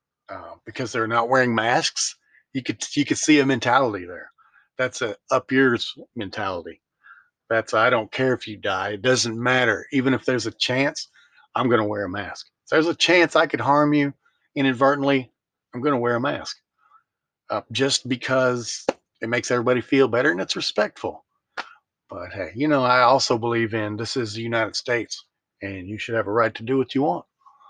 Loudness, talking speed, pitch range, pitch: -22 LUFS, 195 wpm, 115-135 Hz, 125 Hz